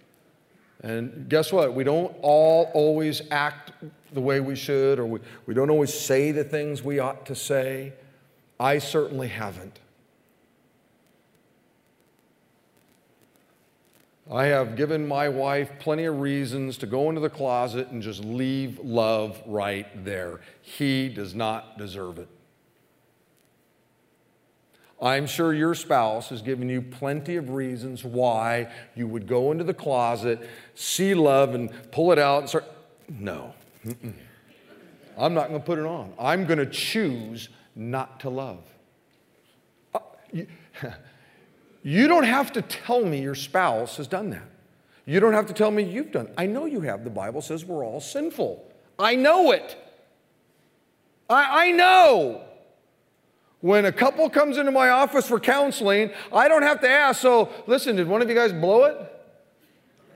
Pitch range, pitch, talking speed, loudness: 125-195 Hz, 145 Hz, 150 wpm, -23 LUFS